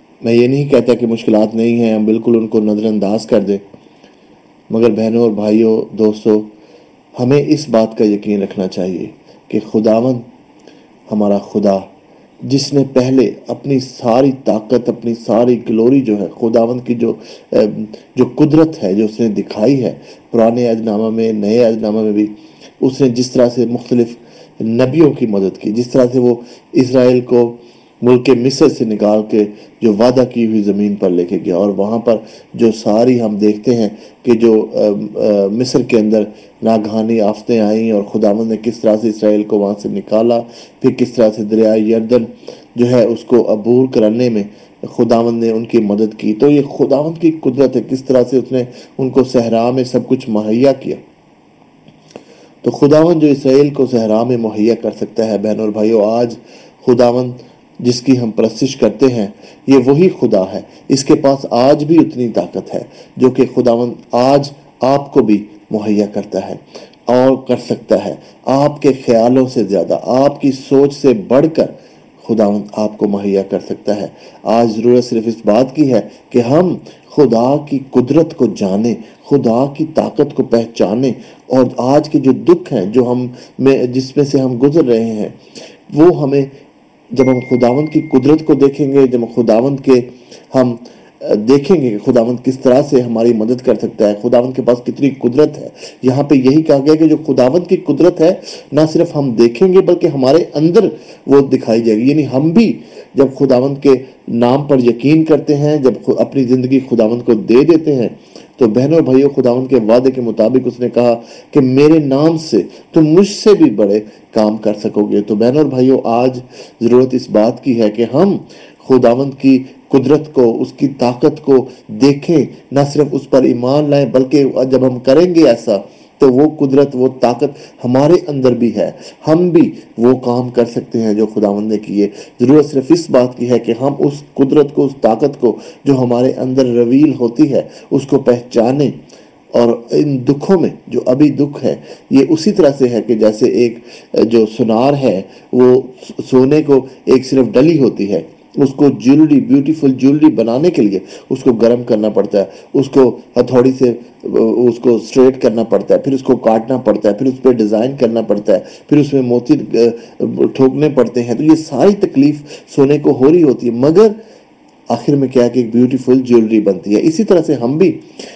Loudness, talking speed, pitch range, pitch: -12 LUFS, 190 wpm, 115-140 Hz, 125 Hz